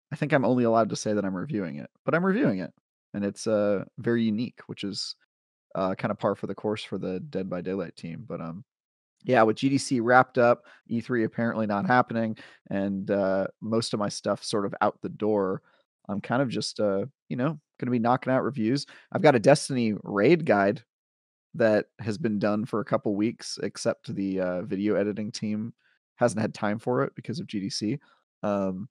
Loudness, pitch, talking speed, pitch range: -27 LUFS, 110 Hz, 205 wpm, 100-120 Hz